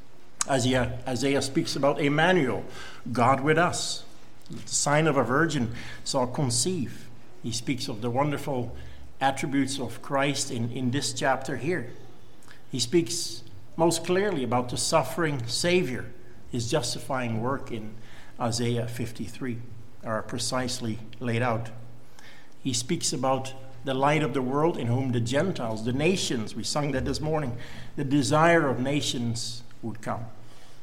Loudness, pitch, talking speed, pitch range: -27 LUFS, 130 Hz, 135 wpm, 120-145 Hz